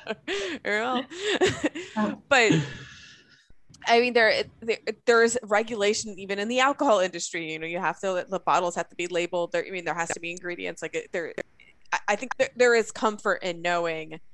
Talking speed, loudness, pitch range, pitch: 170 wpm, -26 LUFS, 175-255 Hz, 210 Hz